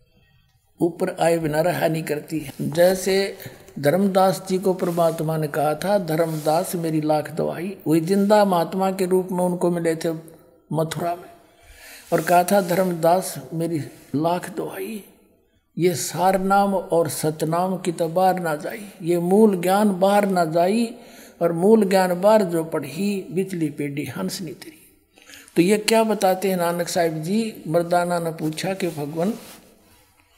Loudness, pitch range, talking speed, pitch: -21 LUFS, 160-190 Hz, 150 wpm, 175 Hz